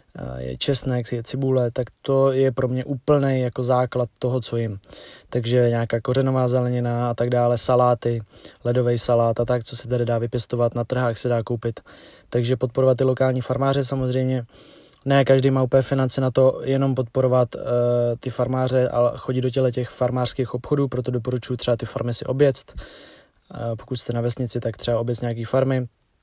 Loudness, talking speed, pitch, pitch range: -21 LUFS, 180 wpm, 125 Hz, 120-130 Hz